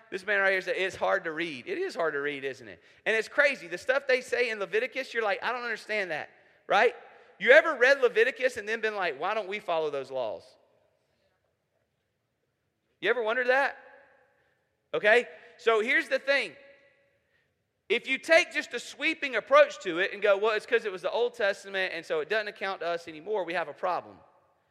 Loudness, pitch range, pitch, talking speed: -27 LUFS, 195-275 Hz, 230 Hz, 210 wpm